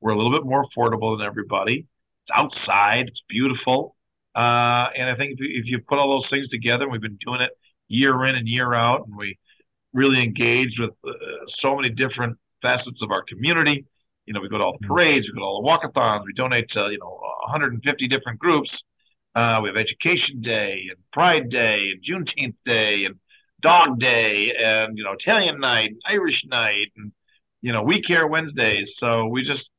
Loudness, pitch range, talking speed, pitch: -20 LUFS, 110-135 Hz, 200 wpm, 120 Hz